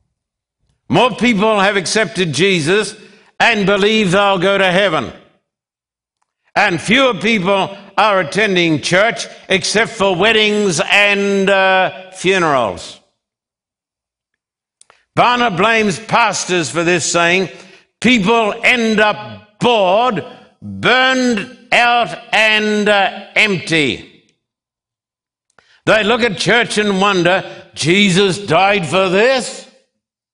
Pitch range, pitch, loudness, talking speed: 185-220 Hz, 200 Hz, -13 LUFS, 95 wpm